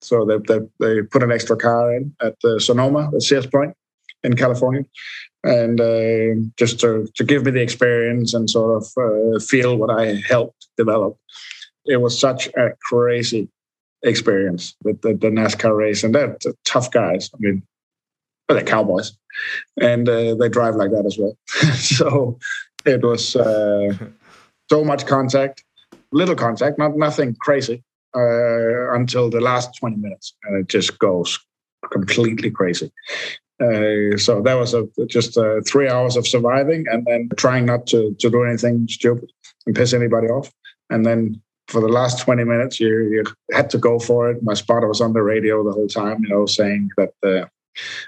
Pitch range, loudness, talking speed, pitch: 110-125 Hz, -18 LUFS, 170 wpm, 120 Hz